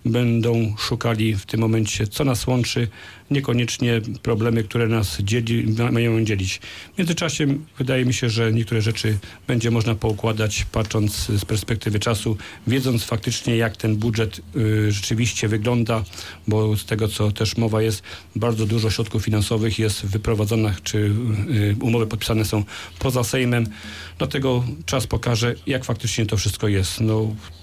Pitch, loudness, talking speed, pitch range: 110 Hz, -22 LUFS, 145 wpm, 105-120 Hz